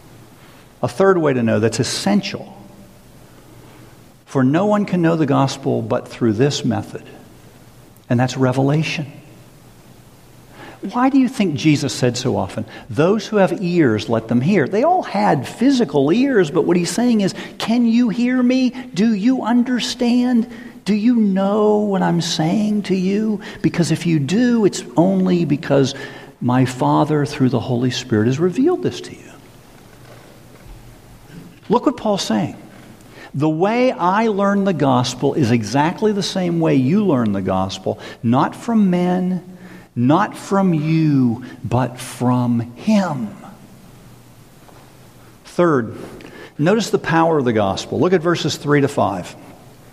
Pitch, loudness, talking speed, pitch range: 170 Hz, -17 LUFS, 145 wpm, 130-210 Hz